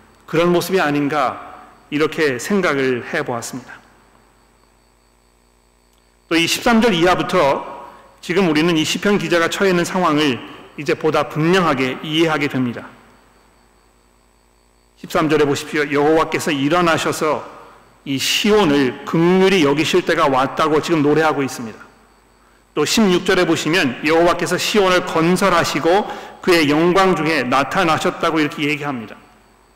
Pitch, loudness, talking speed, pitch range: 155 Hz, -16 LUFS, 280 characters per minute, 130-175 Hz